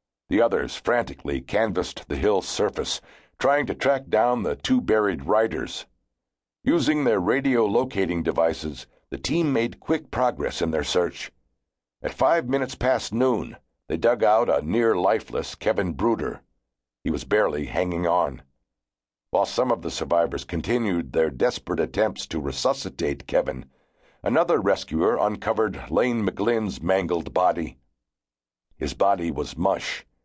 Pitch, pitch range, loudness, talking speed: 70 Hz, 60-95 Hz, -24 LUFS, 135 wpm